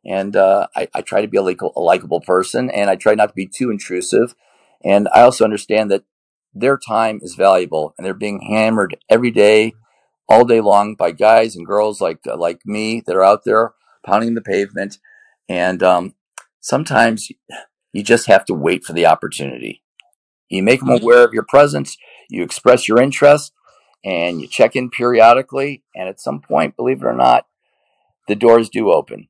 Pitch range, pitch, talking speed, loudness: 95-120 Hz, 105 Hz, 190 wpm, -15 LUFS